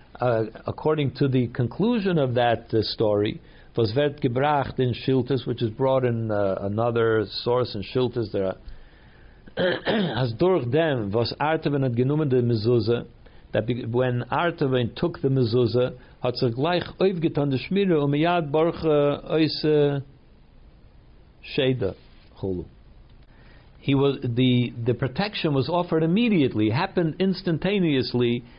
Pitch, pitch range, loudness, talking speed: 130 Hz, 120-155 Hz, -24 LUFS, 120 wpm